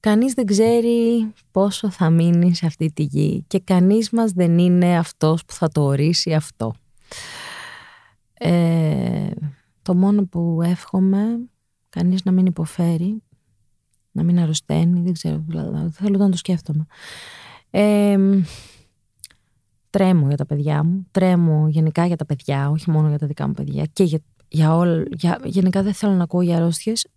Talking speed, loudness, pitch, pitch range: 155 wpm, -19 LUFS, 170 Hz, 150-195 Hz